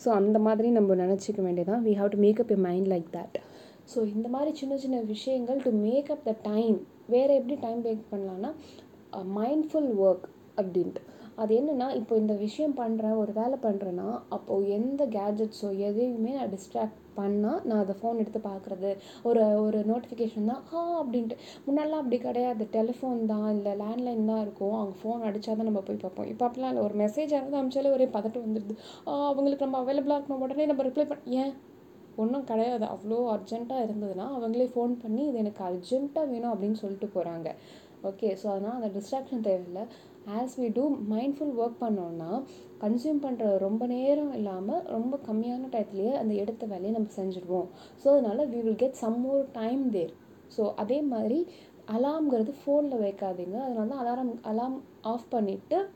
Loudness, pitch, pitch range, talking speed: -30 LUFS, 225 Hz, 210-260 Hz, 165 wpm